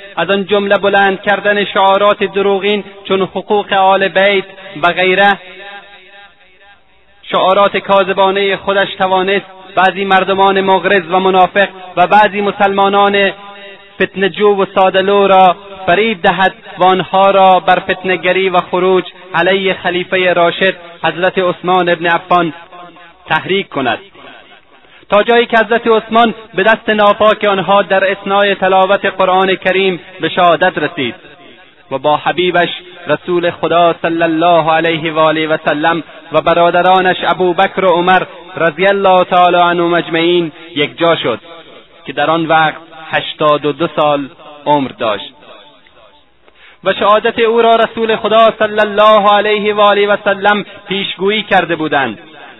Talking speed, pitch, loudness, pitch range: 130 wpm, 190 Hz, -11 LUFS, 175-200 Hz